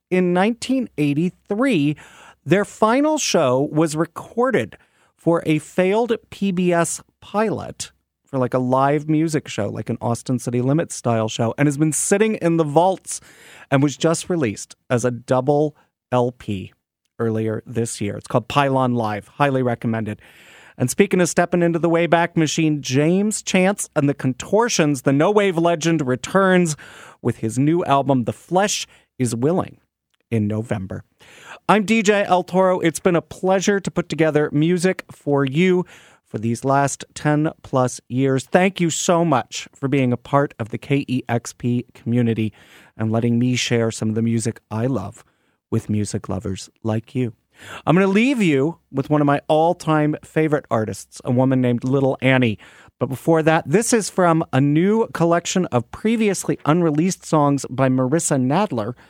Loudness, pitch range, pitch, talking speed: -20 LUFS, 125-170 Hz, 145 Hz, 160 wpm